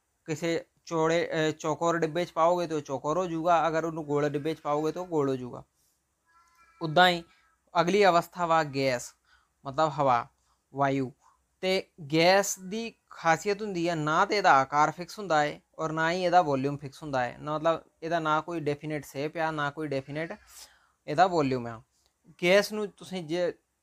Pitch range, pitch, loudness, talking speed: 145-175 Hz, 160 Hz, -28 LUFS, 170 wpm